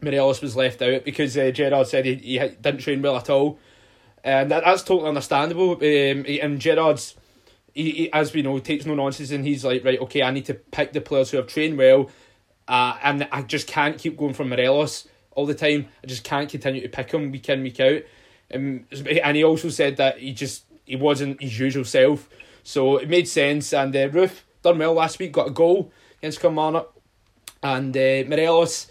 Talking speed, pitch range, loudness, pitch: 210 wpm, 130-150 Hz, -21 LUFS, 140 Hz